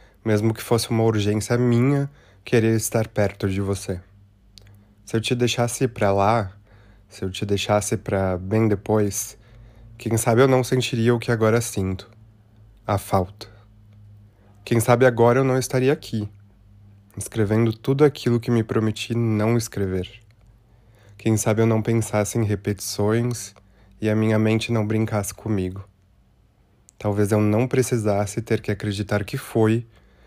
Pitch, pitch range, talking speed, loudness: 110 Hz, 100-115 Hz, 145 wpm, -22 LUFS